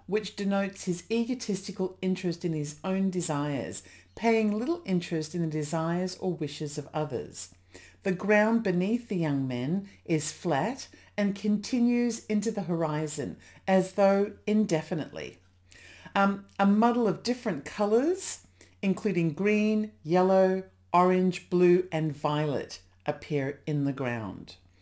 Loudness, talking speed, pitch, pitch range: -28 LUFS, 125 wpm, 180 Hz, 150-205 Hz